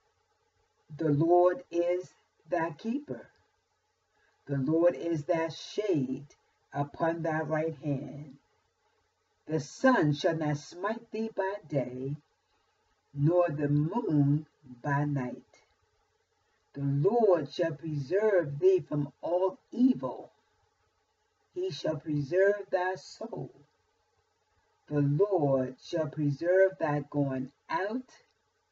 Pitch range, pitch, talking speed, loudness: 145-200 Hz, 165 Hz, 100 wpm, -30 LUFS